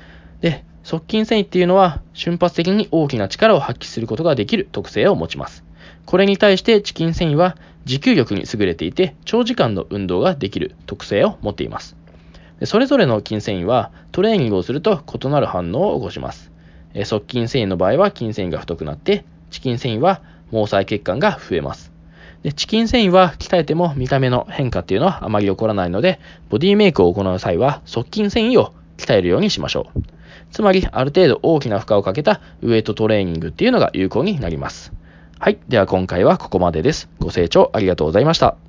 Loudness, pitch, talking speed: -17 LUFS, 115 Hz, 410 characters per minute